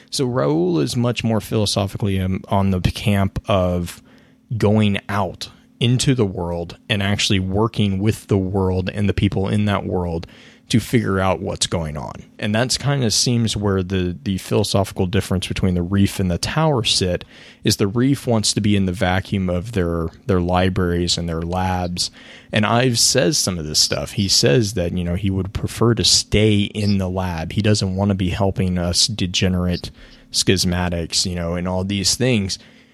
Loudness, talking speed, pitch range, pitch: -19 LUFS, 185 wpm, 90-110 Hz, 100 Hz